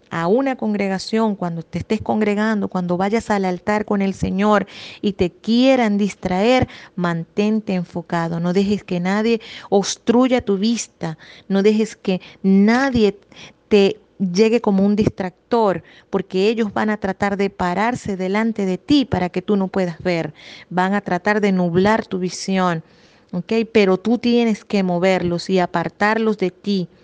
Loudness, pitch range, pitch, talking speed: -19 LUFS, 180-215 Hz, 200 Hz, 155 wpm